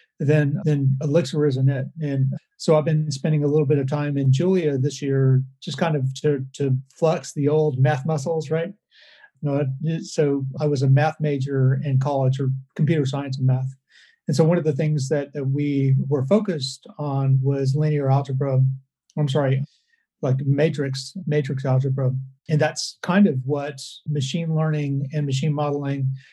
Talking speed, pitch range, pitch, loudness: 175 wpm, 135-155 Hz, 145 Hz, -22 LUFS